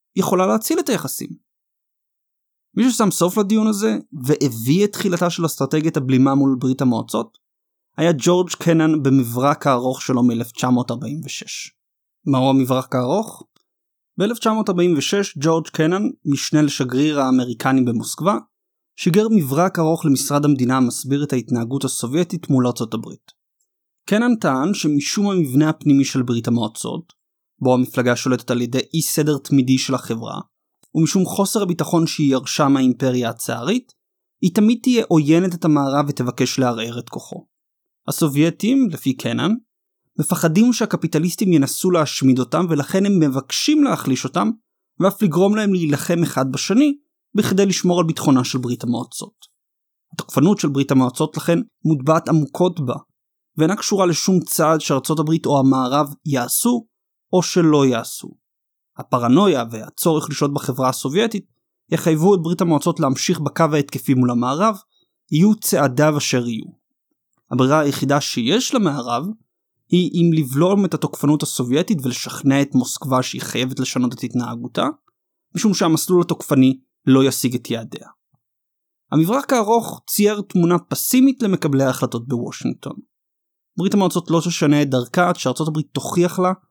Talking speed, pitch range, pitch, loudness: 130 wpm, 130-185 Hz, 155 Hz, -18 LUFS